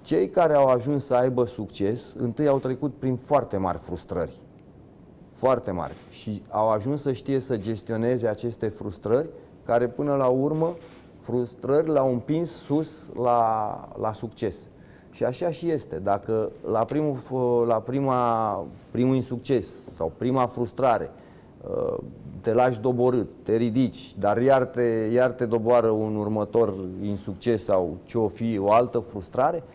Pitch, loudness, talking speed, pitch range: 120 Hz, -25 LUFS, 145 wpm, 110-135 Hz